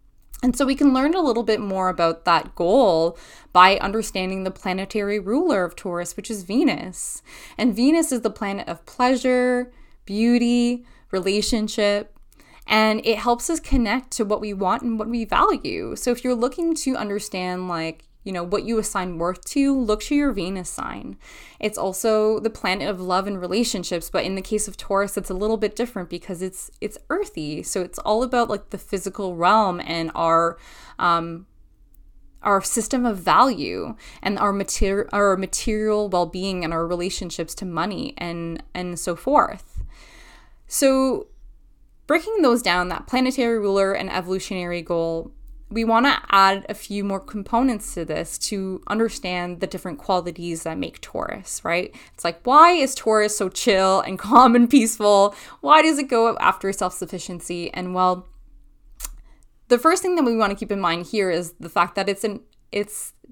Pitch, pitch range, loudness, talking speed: 205 Hz, 180-240 Hz, -21 LUFS, 175 wpm